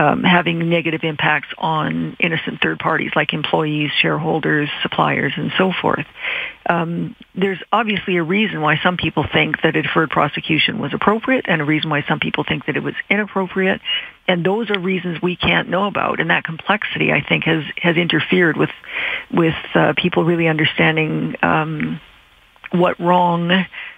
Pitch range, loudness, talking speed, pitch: 155-190 Hz, -17 LUFS, 165 wpm, 175 Hz